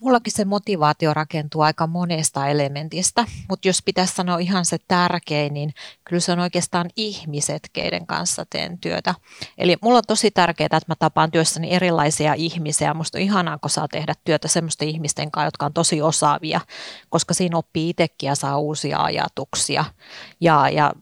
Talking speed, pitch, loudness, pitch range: 170 wpm, 165 Hz, -21 LUFS, 150-180 Hz